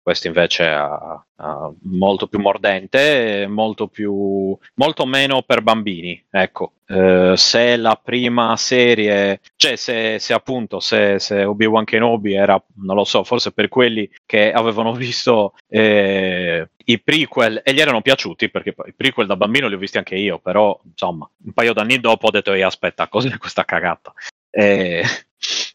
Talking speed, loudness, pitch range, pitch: 155 wpm, -16 LUFS, 100-115 Hz, 105 Hz